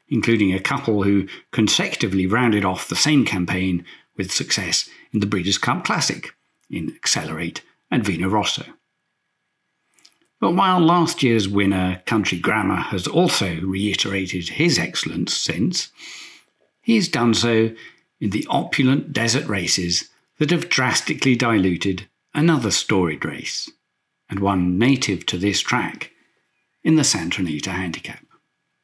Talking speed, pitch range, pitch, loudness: 125 wpm, 95-130 Hz, 105 Hz, -20 LUFS